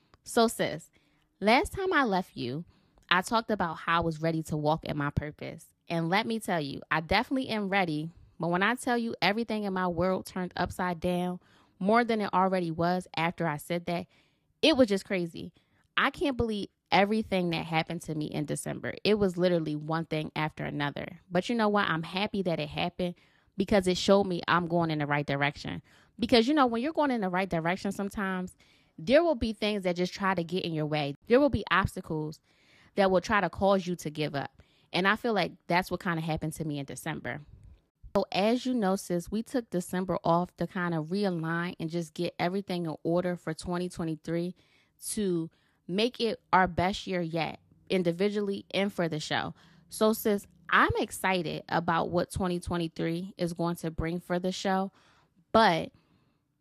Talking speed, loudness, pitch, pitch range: 195 wpm, -29 LUFS, 180 Hz, 165-200 Hz